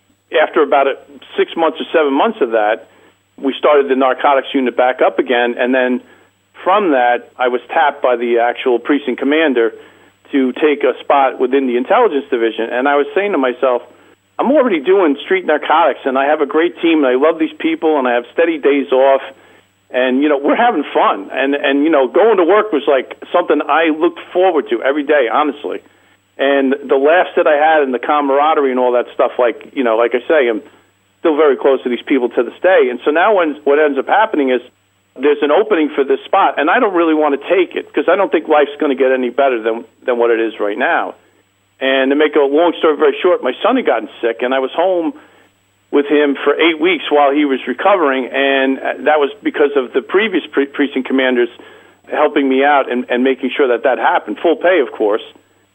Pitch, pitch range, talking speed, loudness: 140 Hz, 130-155 Hz, 220 wpm, -14 LUFS